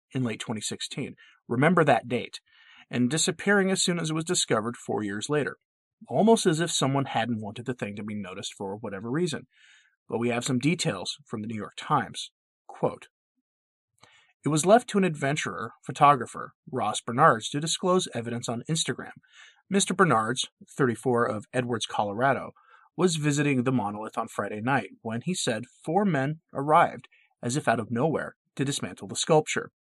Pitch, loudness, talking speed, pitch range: 135 Hz, -27 LUFS, 170 wpm, 120-170 Hz